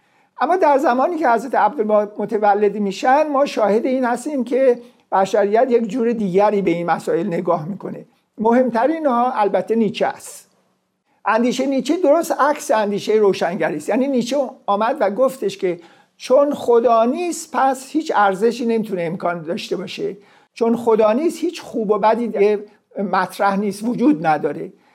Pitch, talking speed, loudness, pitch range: 225 Hz, 150 wpm, -18 LUFS, 200-265 Hz